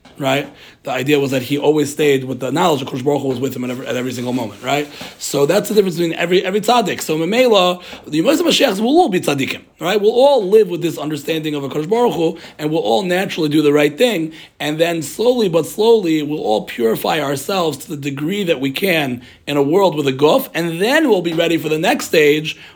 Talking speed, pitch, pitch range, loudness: 250 wpm, 160 Hz, 145-190 Hz, -16 LUFS